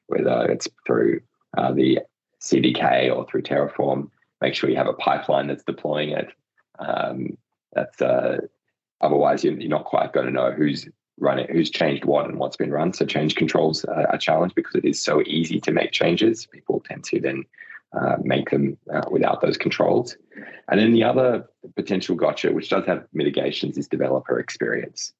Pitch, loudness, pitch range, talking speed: 75 Hz, -22 LUFS, 70-100 Hz, 175 wpm